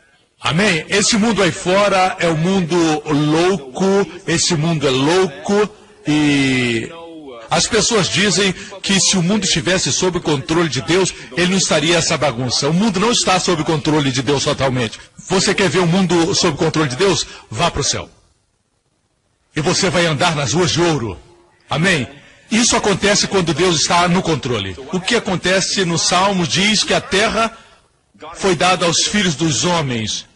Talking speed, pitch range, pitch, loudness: 175 wpm, 150-195 Hz, 175 Hz, -15 LUFS